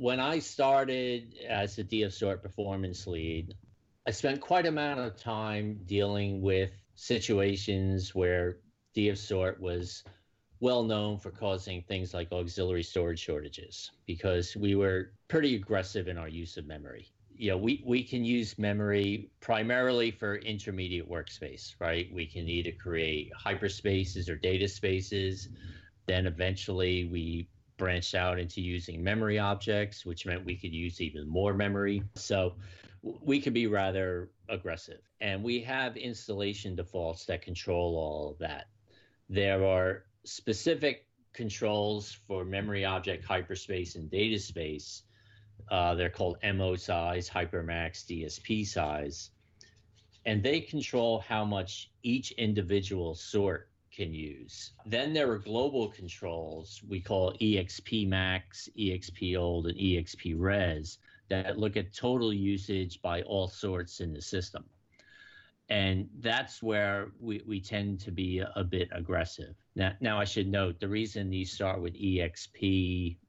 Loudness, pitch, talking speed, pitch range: -33 LUFS, 95 Hz, 140 wpm, 90-105 Hz